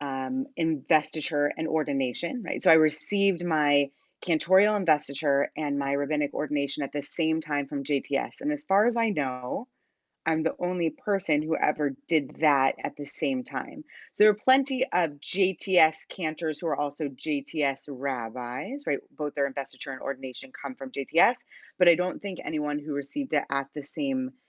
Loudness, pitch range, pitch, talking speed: -27 LUFS, 140-180 Hz, 150 Hz, 175 wpm